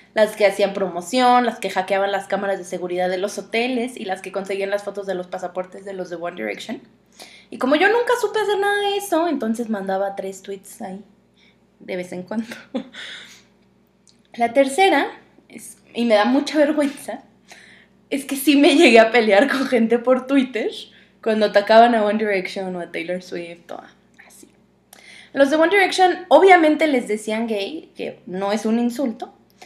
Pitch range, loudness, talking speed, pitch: 195-275 Hz, -19 LUFS, 180 wpm, 225 Hz